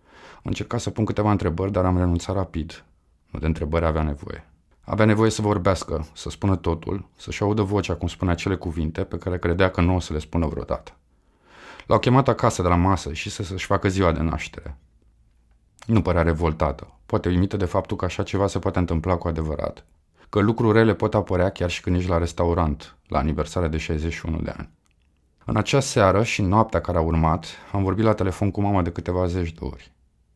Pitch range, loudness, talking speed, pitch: 80-100 Hz, -23 LUFS, 200 wpm, 90 Hz